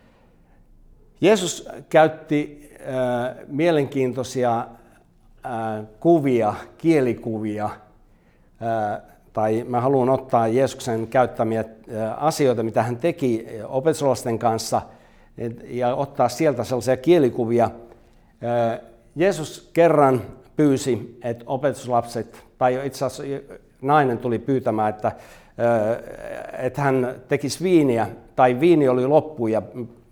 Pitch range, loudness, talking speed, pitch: 115-140 Hz, -22 LUFS, 100 wpm, 125 Hz